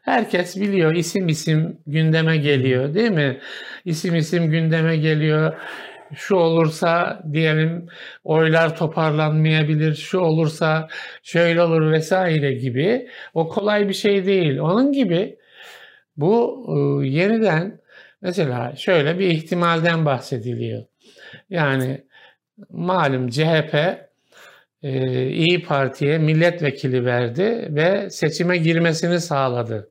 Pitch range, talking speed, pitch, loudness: 150-180 Hz, 95 wpm, 160 Hz, -19 LUFS